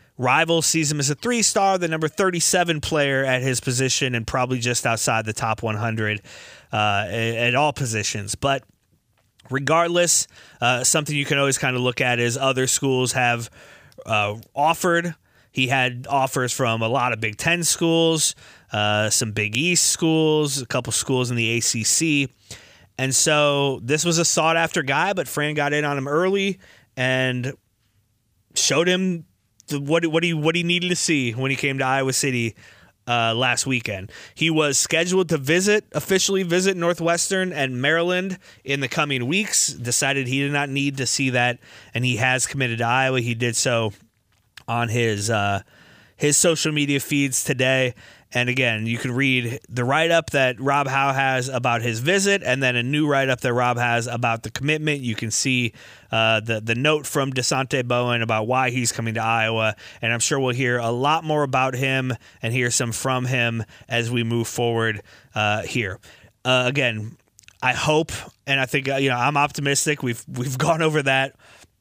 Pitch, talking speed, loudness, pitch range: 130 Hz, 180 wpm, -21 LUFS, 115-150 Hz